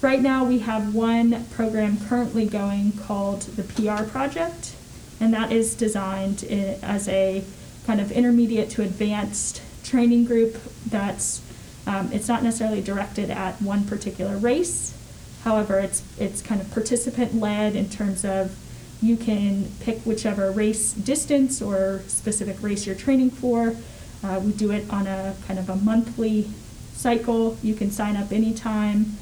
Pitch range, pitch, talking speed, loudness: 200-230 Hz, 215 Hz, 150 wpm, -24 LUFS